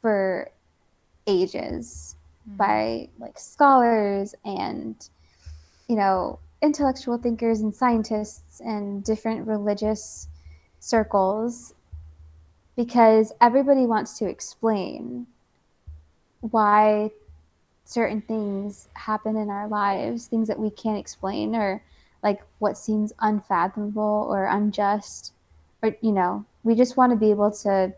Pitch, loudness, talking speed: 205 Hz, -23 LUFS, 105 wpm